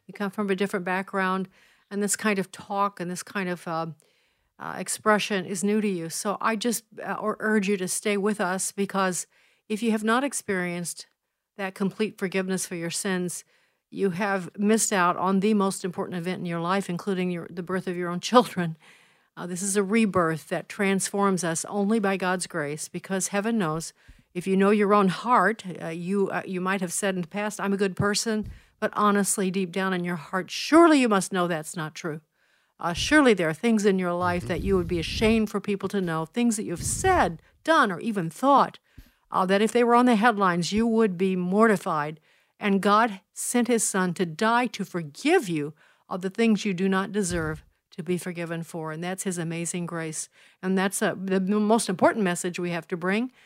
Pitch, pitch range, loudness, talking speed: 195 Hz, 180-210 Hz, -25 LUFS, 210 wpm